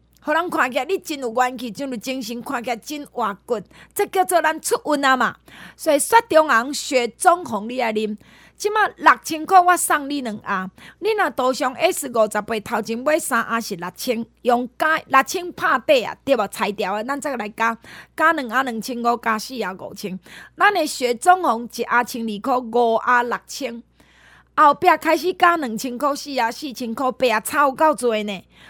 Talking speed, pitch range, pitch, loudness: 265 characters per minute, 230-315 Hz, 255 Hz, -20 LUFS